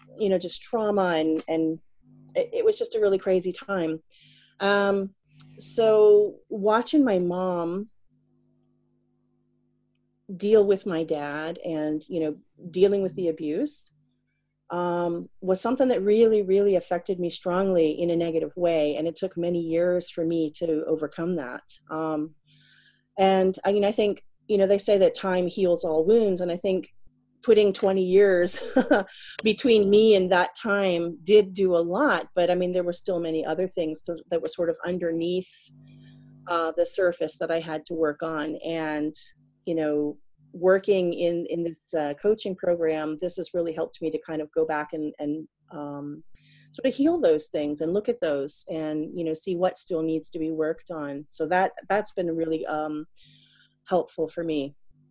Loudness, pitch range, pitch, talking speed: -25 LUFS, 155-195 Hz, 170 Hz, 170 wpm